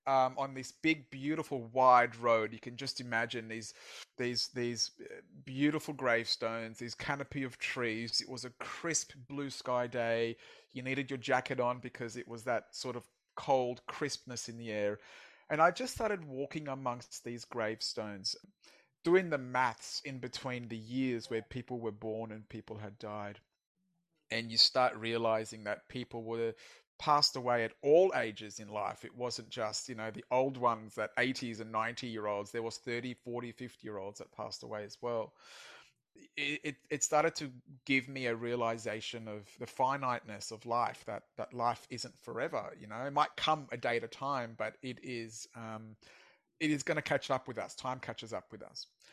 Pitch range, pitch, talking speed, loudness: 115-135 Hz, 120 Hz, 185 wpm, -35 LUFS